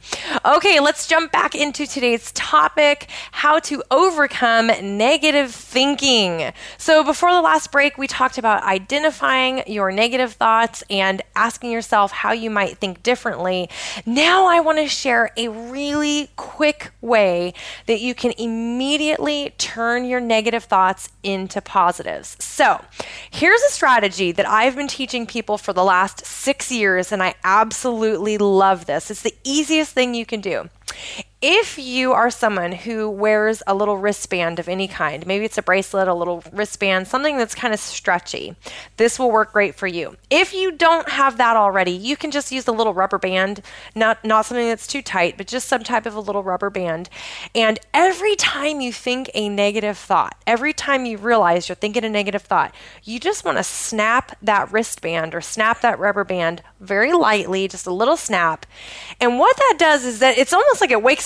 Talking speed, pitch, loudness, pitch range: 180 wpm, 225 Hz, -18 LUFS, 200-265 Hz